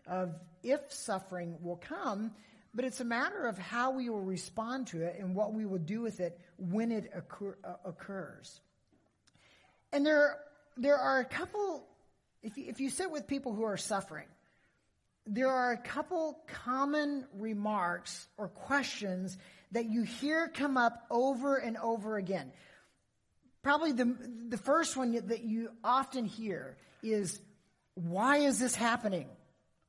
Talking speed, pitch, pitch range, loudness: 150 wpm, 230 Hz, 195-270 Hz, -35 LUFS